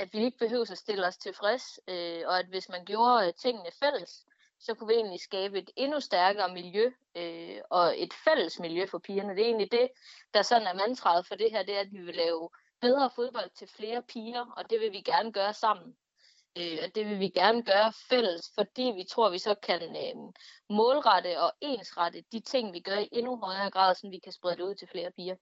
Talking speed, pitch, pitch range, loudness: 230 wpm, 205 Hz, 180-235 Hz, -30 LUFS